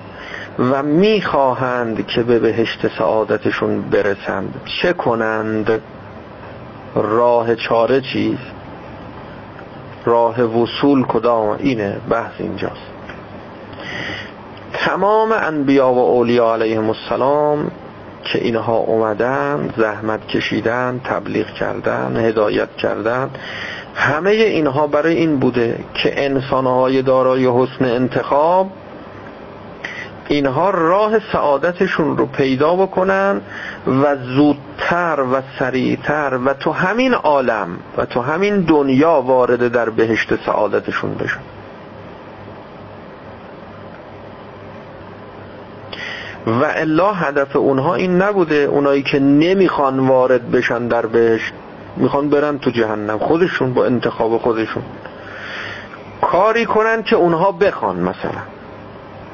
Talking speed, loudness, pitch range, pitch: 95 wpm, -16 LUFS, 115-155 Hz, 135 Hz